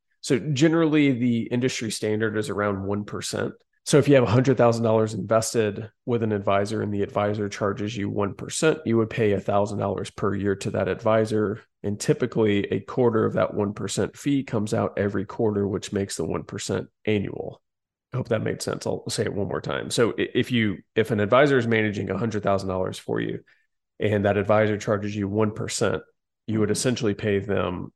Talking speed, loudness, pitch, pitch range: 175 wpm, -24 LUFS, 105 Hz, 100-115 Hz